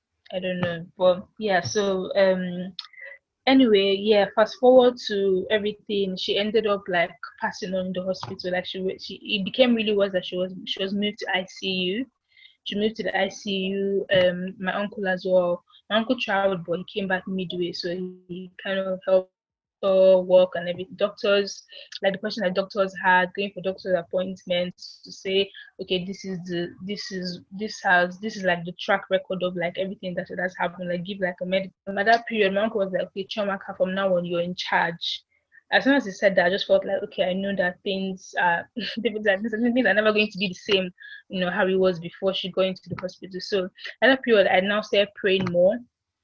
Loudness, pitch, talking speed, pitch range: -24 LUFS, 195 Hz, 215 wpm, 185-205 Hz